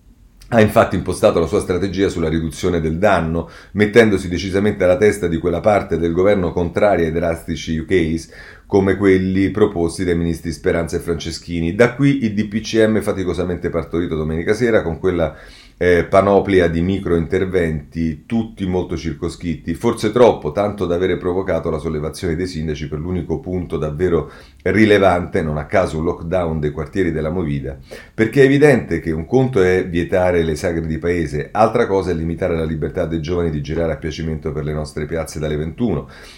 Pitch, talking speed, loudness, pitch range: 85 Hz, 170 wpm, -18 LUFS, 80-95 Hz